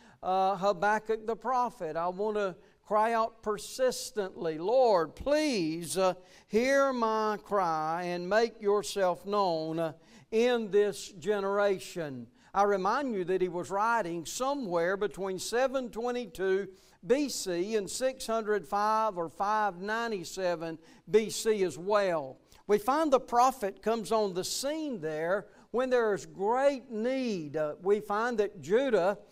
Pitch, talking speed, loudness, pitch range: 205 Hz, 125 wpm, -30 LUFS, 185-230 Hz